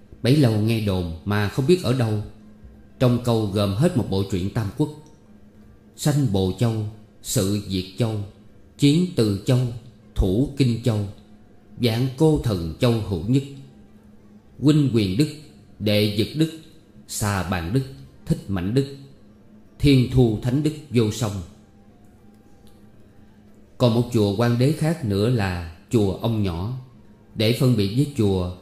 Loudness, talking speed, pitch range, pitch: -22 LUFS, 145 wpm, 105-130 Hz, 105 Hz